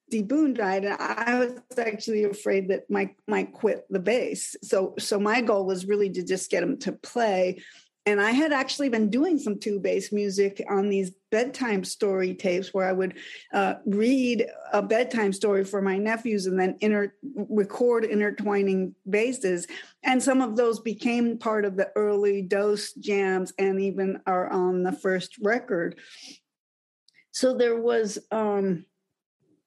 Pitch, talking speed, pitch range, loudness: 205 Hz, 160 wpm, 195-230 Hz, -26 LUFS